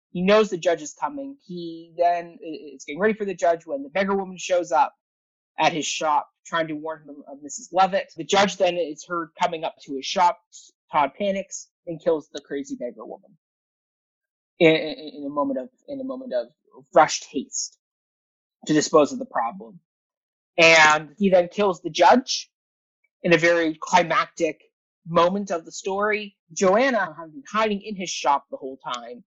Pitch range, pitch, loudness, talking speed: 160-210 Hz, 175 Hz, -22 LUFS, 180 wpm